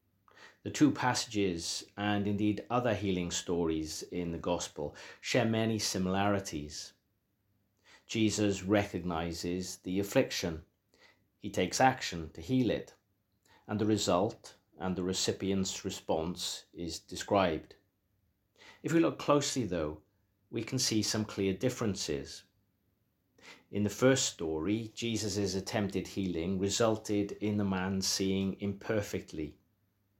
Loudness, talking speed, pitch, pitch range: -33 LUFS, 115 wpm, 100 Hz, 95-110 Hz